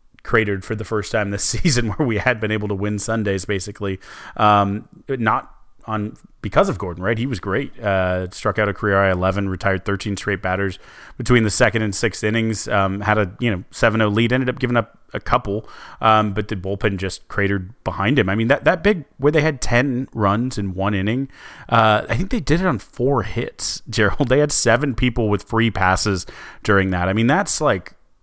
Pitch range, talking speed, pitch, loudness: 100-120 Hz, 215 wpm, 110 Hz, -20 LUFS